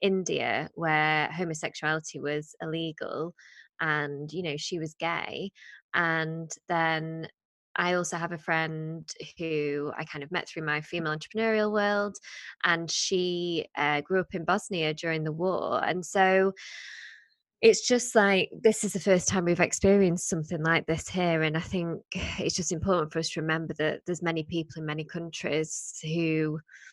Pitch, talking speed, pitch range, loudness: 165 Hz, 160 wpm, 155-180 Hz, -28 LUFS